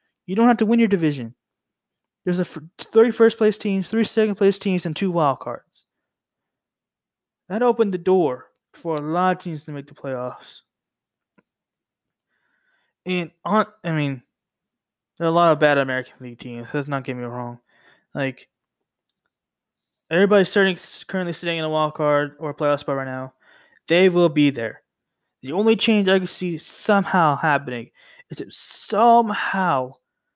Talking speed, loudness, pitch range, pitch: 155 wpm, -21 LUFS, 145-200 Hz, 170 Hz